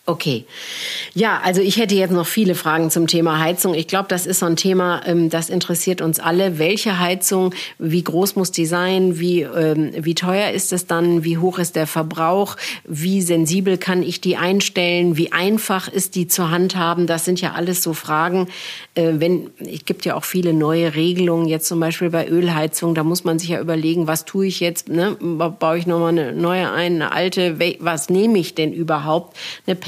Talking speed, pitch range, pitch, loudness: 200 wpm, 165-185 Hz, 175 Hz, -18 LUFS